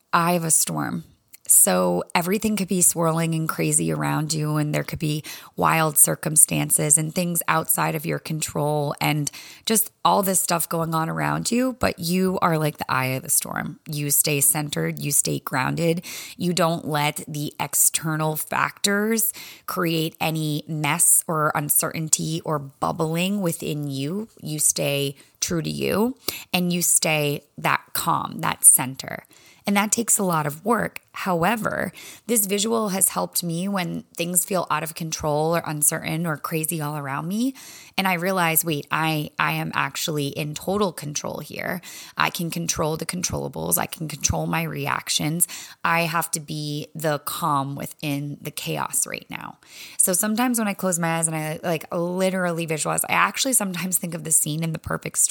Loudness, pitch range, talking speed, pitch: -22 LUFS, 150-180 Hz, 170 wpm, 160 Hz